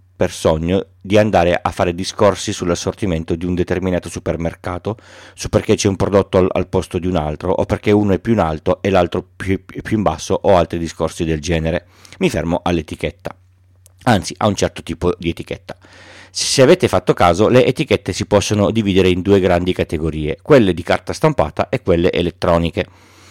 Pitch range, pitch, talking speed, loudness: 85-100 Hz, 90 Hz, 185 wpm, -17 LUFS